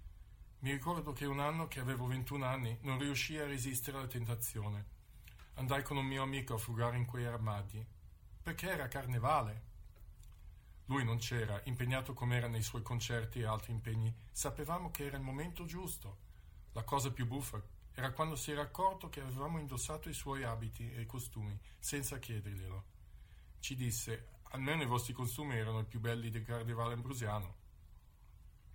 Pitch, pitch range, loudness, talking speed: 120 Hz, 110-140 Hz, -40 LUFS, 165 wpm